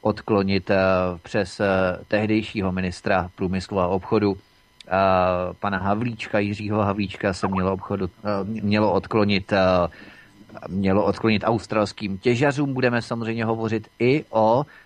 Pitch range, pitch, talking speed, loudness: 95-110 Hz, 100 Hz, 100 wpm, -23 LUFS